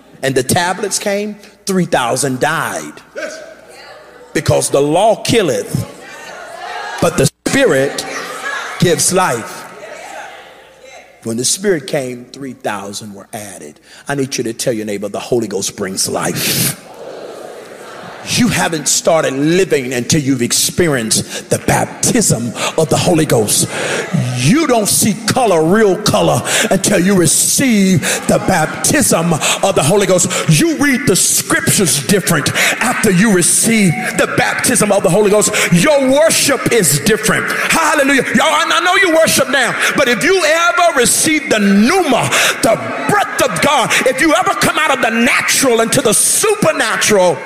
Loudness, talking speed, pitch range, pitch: -12 LUFS, 140 wpm, 150-245 Hz, 195 Hz